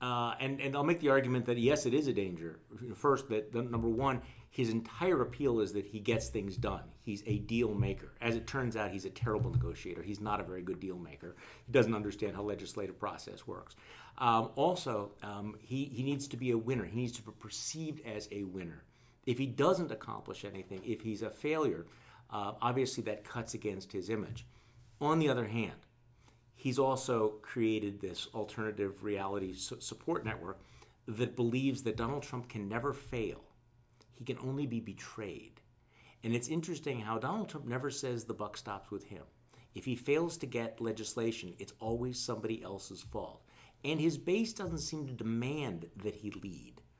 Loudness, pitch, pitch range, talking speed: -36 LUFS, 115 Hz, 105-130 Hz, 185 wpm